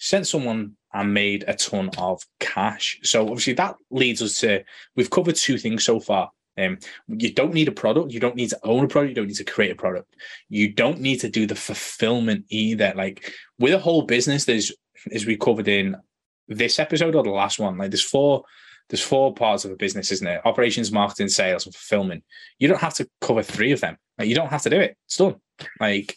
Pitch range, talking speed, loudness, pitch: 105-135 Hz, 225 wpm, -22 LUFS, 115 Hz